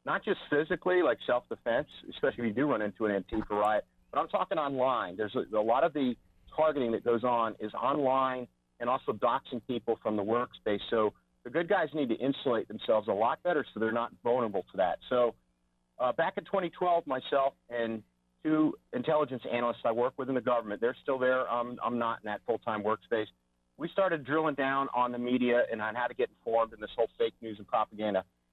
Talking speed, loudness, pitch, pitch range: 205 wpm, -31 LUFS, 120 Hz, 105-135 Hz